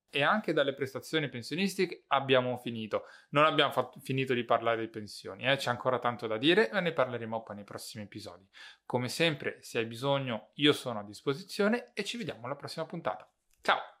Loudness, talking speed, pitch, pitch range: -31 LUFS, 190 wpm, 130 Hz, 115-145 Hz